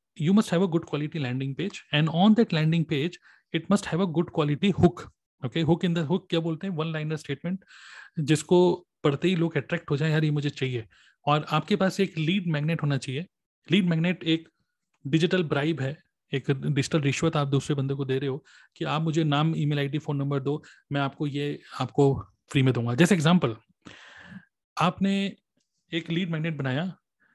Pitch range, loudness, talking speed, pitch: 145-175 Hz, -26 LUFS, 195 wpm, 160 Hz